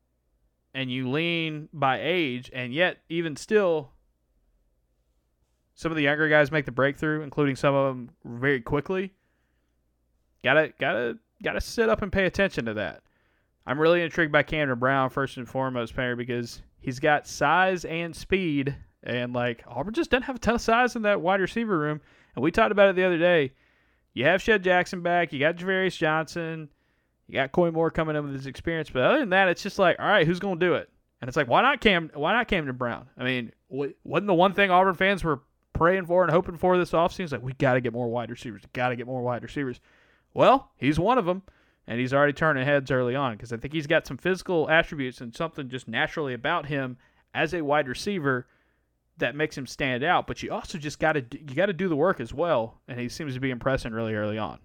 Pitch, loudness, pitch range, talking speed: 150 Hz, -25 LUFS, 125-175 Hz, 225 wpm